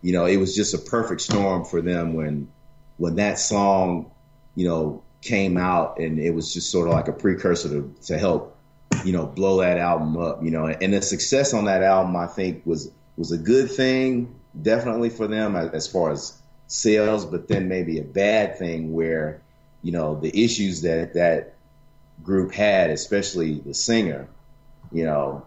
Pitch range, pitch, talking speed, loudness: 80-100 Hz, 90 Hz, 185 wpm, -23 LUFS